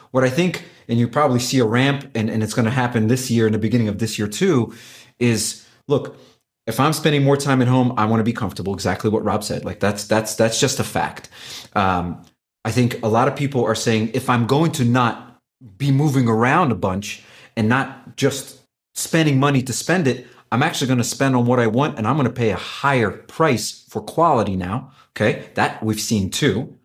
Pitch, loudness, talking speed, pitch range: 120 Hz, -19 LUFS, 225 wpm, 110-130 Hz